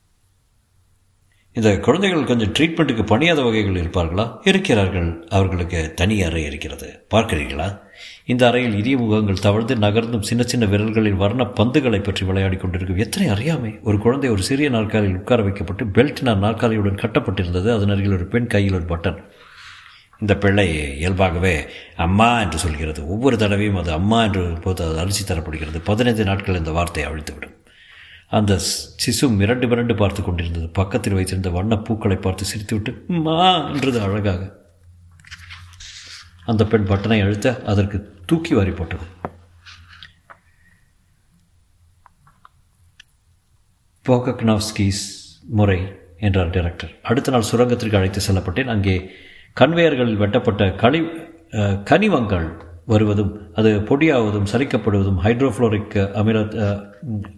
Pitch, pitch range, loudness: 100 Hz, 90-115 Hz, -19 LUFS